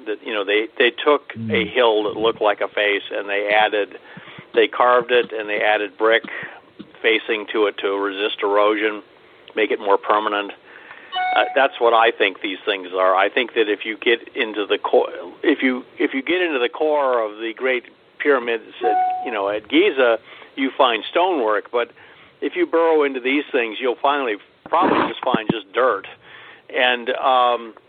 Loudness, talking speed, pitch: -19 LUFS, 185 wpm, 130 Hz